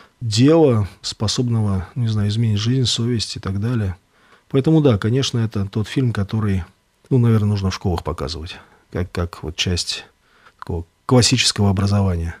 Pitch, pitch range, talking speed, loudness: 105 Hz, 95-120 Hz, 145 wpm, -19 LUFS